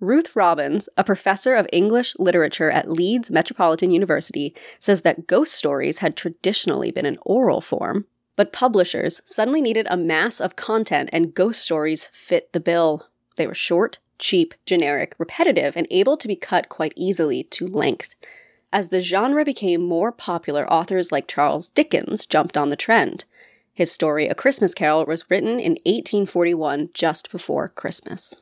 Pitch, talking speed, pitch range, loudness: 190 Hz, 160 wpm, 170-235 Hz, -20 LUFS